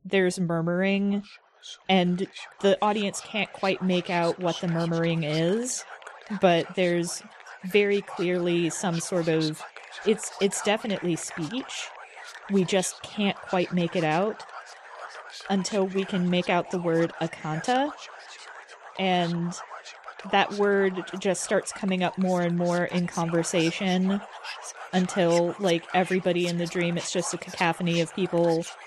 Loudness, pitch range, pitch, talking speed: -26 LUFS, 170-195 Hz, 180 Hz, 130 wpm